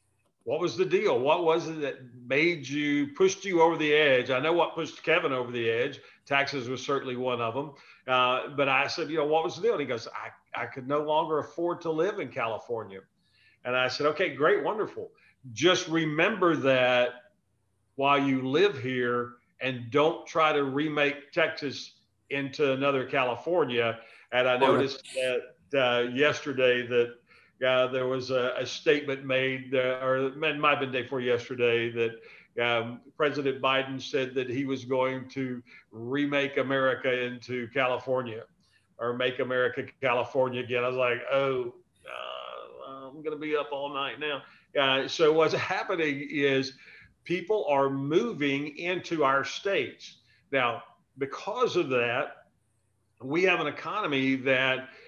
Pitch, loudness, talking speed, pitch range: 135 Hz, -27 LUFS, 165 wpm, 125-150 Hz